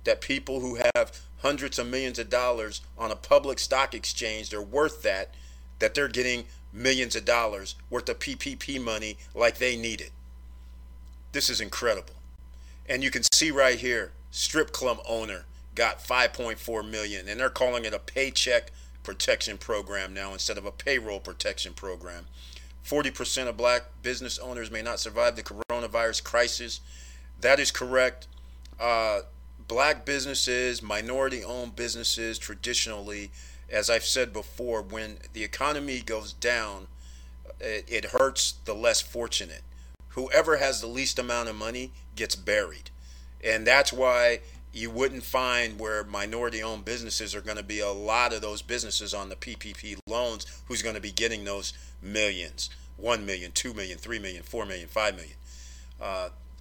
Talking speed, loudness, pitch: 155 wpm, -28 LUFS, 110 Hz